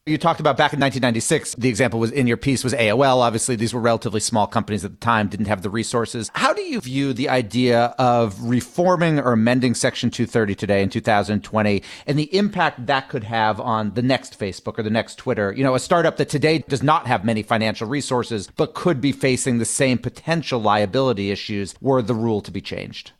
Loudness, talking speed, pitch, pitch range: -20 LUFS, 215 wpm, 120 Hz, 110-135 Hz